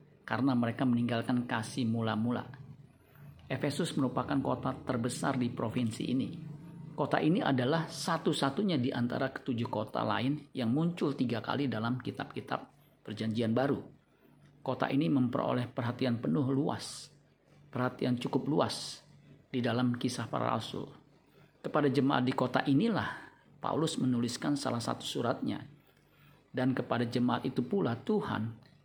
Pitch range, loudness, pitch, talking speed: 120-145 Hz, -33 LUFS, 130 Hz, 125 wpm